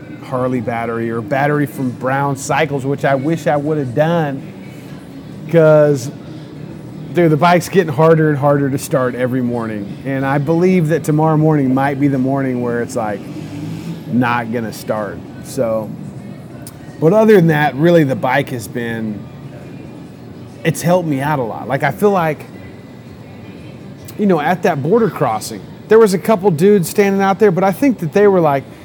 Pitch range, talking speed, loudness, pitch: 135-165 Hz, 170 wpm, -15 LUFS, 150 Hz